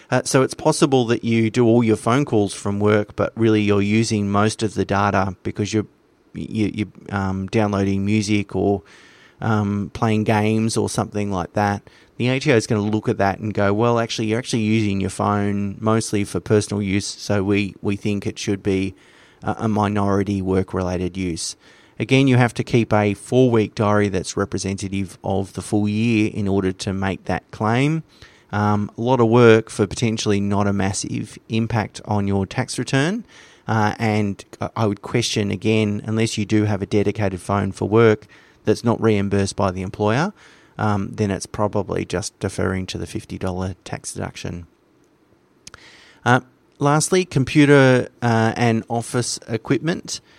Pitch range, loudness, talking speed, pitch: 100-115 Hz, -20 LUFS, 170 wpm, 105 Hz